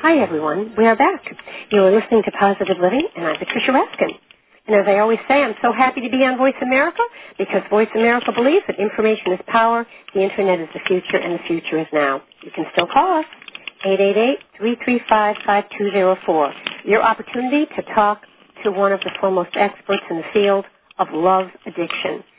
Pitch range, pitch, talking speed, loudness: 190-235 Hz, 205 Hz, 180 wpm, -18 LUFS